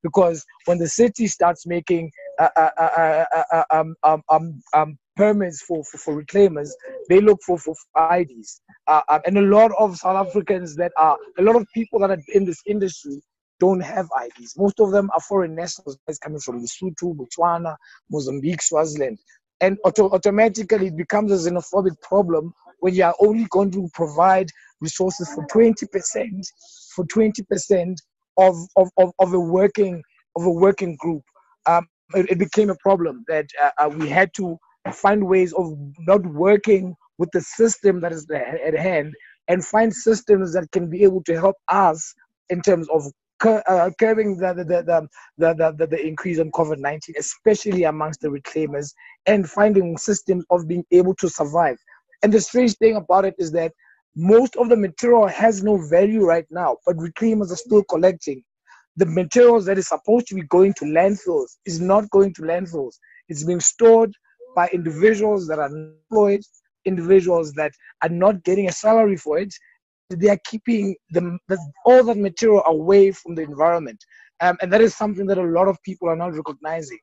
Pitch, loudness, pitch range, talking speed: 185 Hz, -19 LUFS, 165-205 Hz, 175 wpm